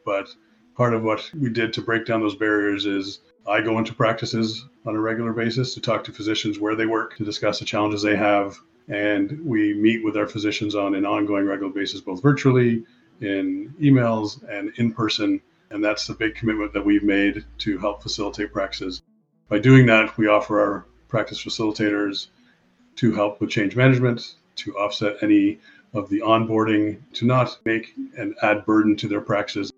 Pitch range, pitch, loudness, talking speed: 105-115 Hz, 110 Hz, -22 LUFS, 185 wpm